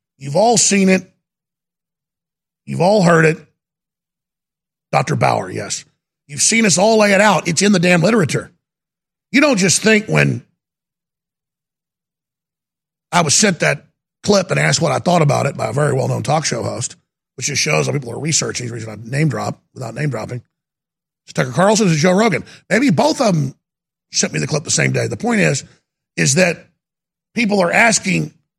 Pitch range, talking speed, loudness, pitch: 150-185 Hz, 185 wpm, -15 LUFS, 165 Hz